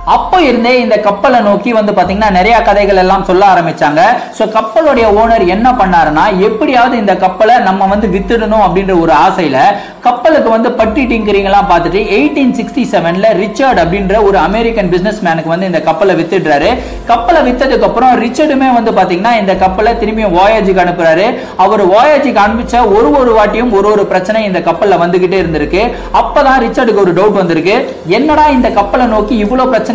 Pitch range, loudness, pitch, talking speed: 190-240 Hz, -9 LUFS, 215 Hz, 160 wpm